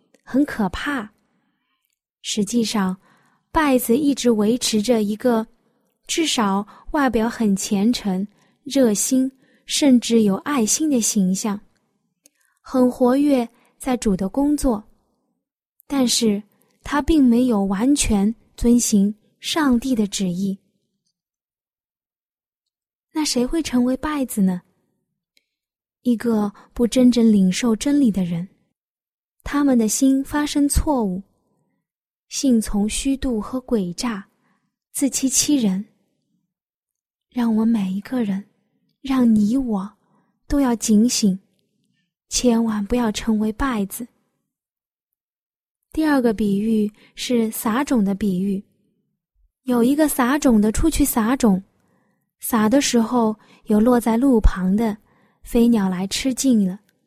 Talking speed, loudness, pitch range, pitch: 160 characters per minute, -20 LUFS, 205-255 Hz, 230 Hz